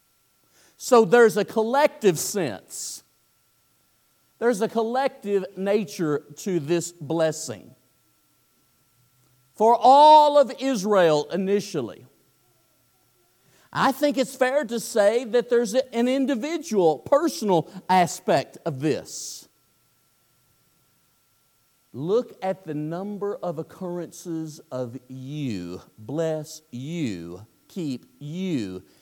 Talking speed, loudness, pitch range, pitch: 90 wpm, -23 LUFS, 135-230 Hz, 170 Hz